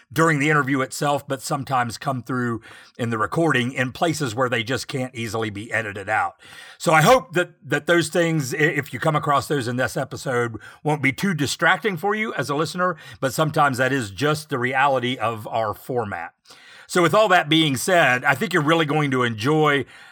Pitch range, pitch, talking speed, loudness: 125-160 Hz, 140 Hz, 205 wpm, -21 LUFS